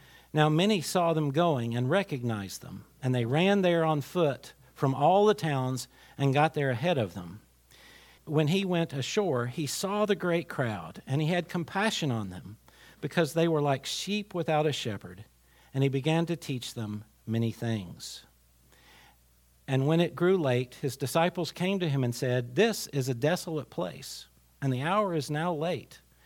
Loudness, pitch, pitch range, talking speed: -29 LUFS, 145 Hz, 125-170 Hz, 180 wpm